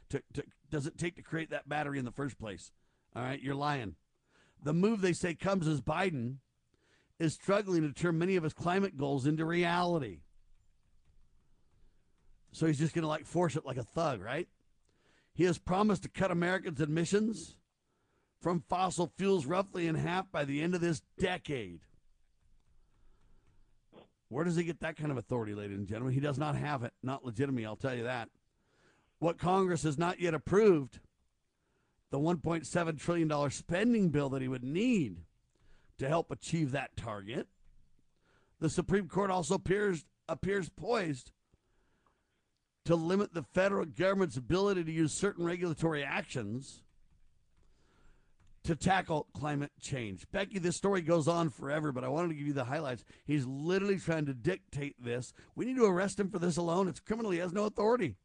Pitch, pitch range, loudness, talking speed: 160 Hz, 140-180 Hz, -34 LUFS, 170 wpm